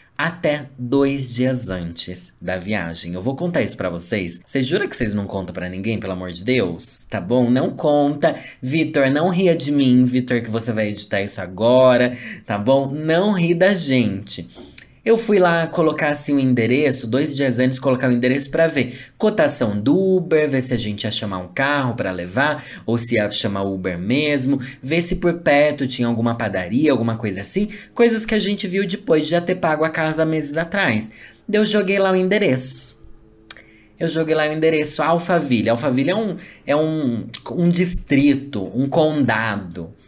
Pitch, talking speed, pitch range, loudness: 130 Hz, 190 wpm, 110-160 Hz, -19 LUFS